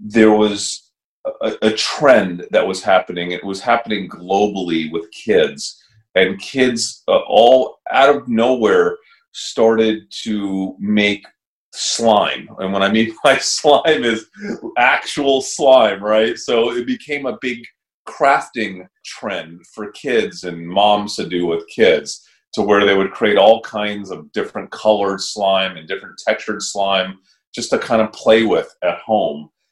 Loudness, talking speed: -16 LUFS, 145 wpm